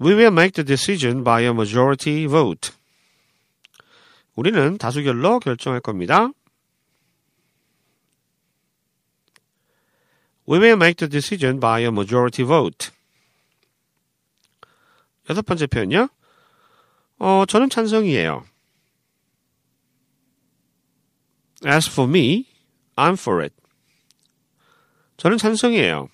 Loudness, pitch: -18 LUFS, 155 Hz